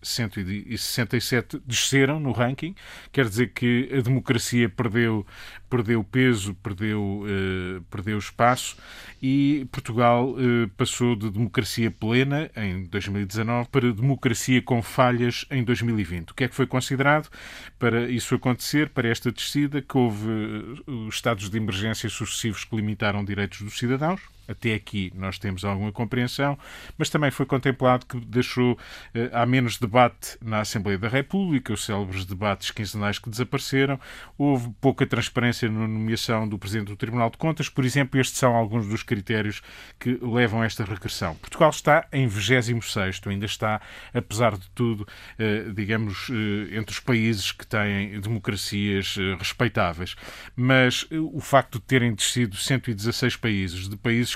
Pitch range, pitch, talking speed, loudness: 105-130 Hz, 115 Hz, 150 wpm, -25 LUFS